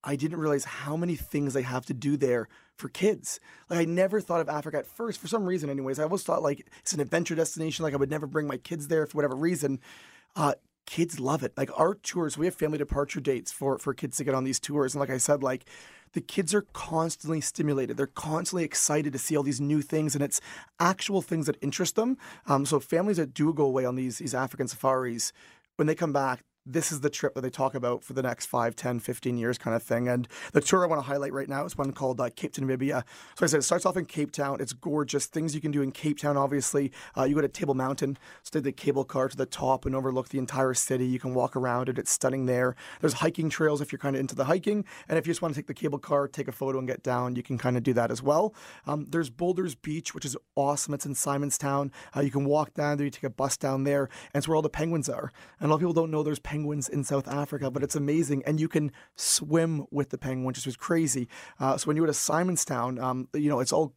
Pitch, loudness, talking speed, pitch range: 145 Hz, -29 LUFS, 270 wpm, 135-155 Hz